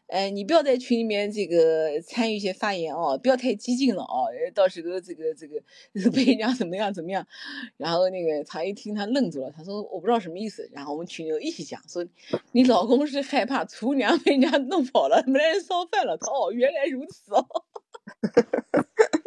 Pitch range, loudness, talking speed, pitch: 185-280 Hz, -25 LUFS, 300 characters per minute, 235 Hz